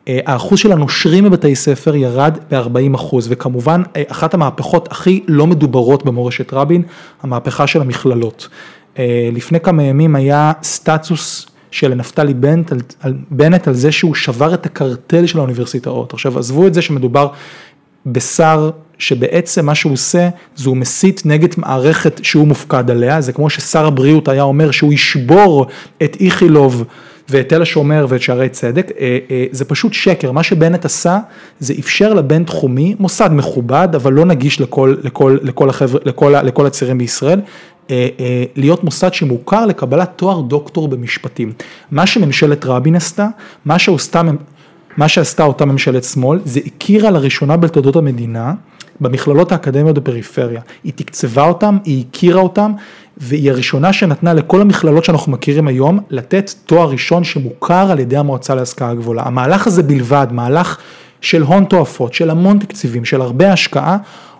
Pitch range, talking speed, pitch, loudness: 130-170 Hz, 145 wpm, 150 Hz, -12 LUFS